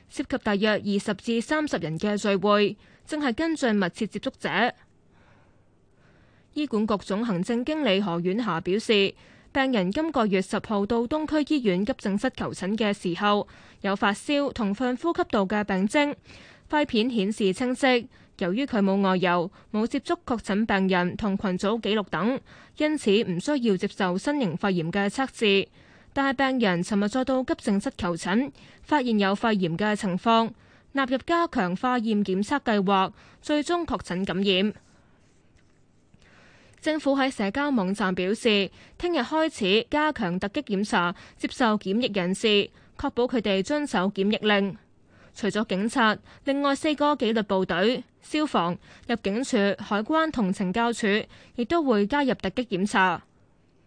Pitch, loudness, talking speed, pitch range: 215 Hz, -25 LUFS, 230 characters per minute, 195-265 Hz